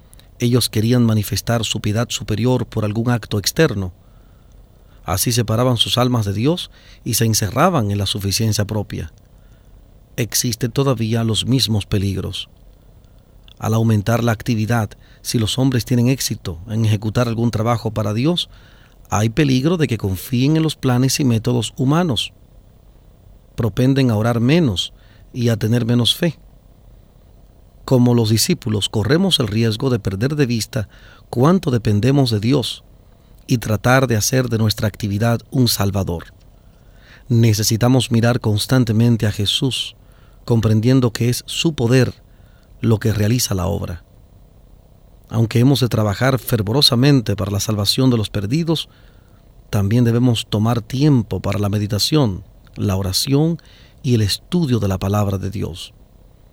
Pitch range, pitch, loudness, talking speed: 105-125 Hz, 115 Hz, -18 LUFS, 135 wpm